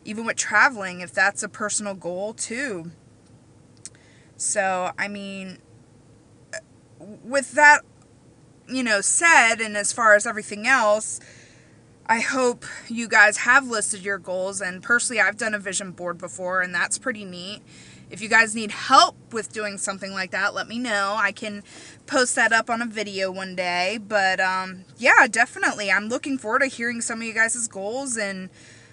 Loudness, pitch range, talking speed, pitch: -21 LUFS, 185-230 Hz, 170 wpm, 205 Hz